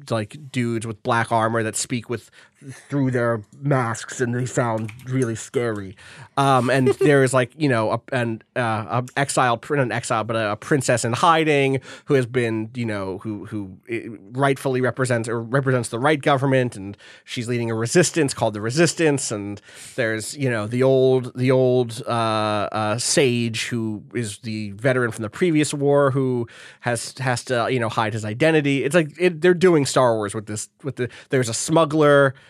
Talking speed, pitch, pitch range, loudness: 180 wpm, 125 Hz, 115-135 Hz, -21 LUFS